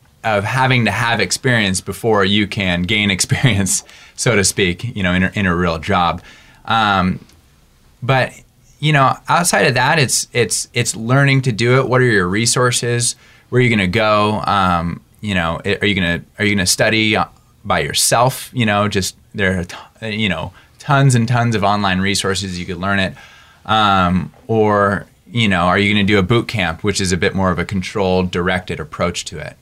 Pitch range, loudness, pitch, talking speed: 95-115 Hz, -16 LUFS, 100 Hz, 200 wpm